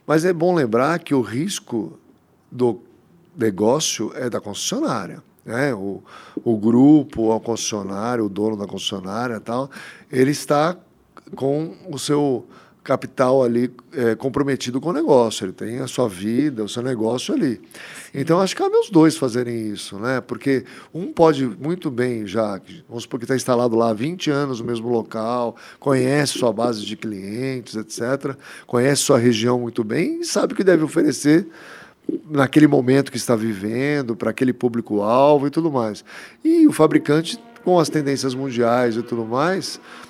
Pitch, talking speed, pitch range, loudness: 130 Hz, 165 wpm, 115-150 Hz, -20 LUFS